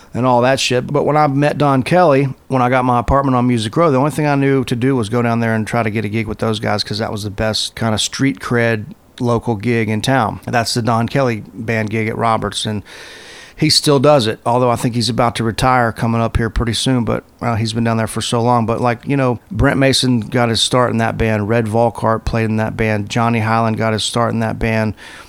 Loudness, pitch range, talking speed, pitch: -16 LUFS, 110-125 Hz, 265 wpm, 115 Hz